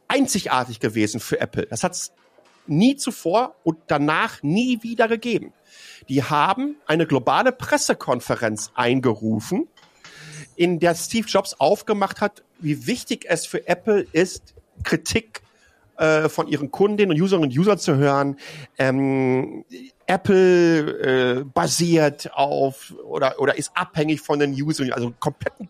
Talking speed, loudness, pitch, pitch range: 135 wpm, -21 LUFS, 155 Hz, 135-200 Hz